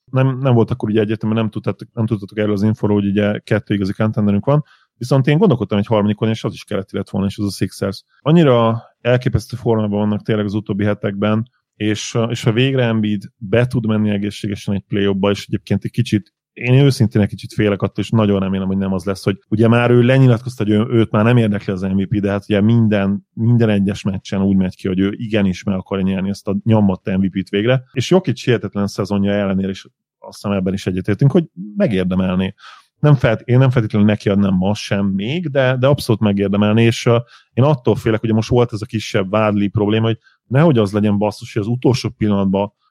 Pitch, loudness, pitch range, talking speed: 105 Hz, -17 LUFS, 100-120 Hz, 210 wpm